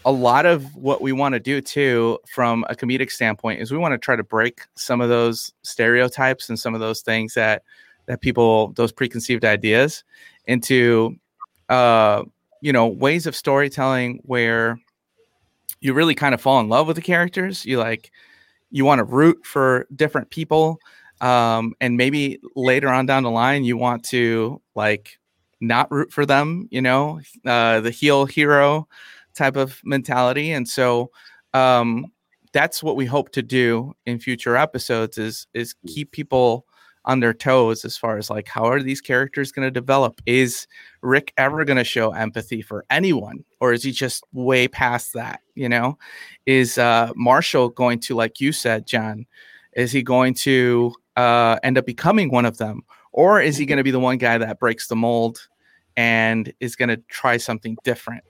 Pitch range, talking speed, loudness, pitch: 115-135 Hz, 180 wpm, -19 LUFS, 125 Hz